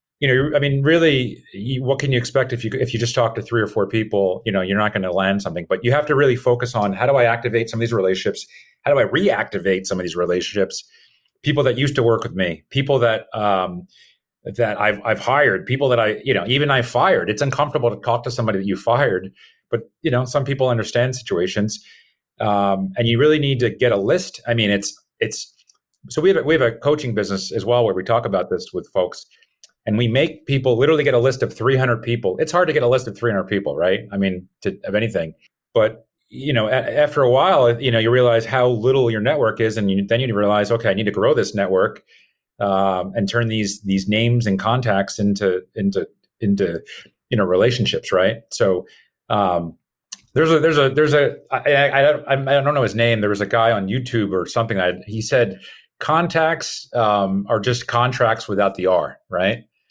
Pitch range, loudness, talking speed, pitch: 100-130 Hz, -19 LUFS, 225 wpm, 115 Hz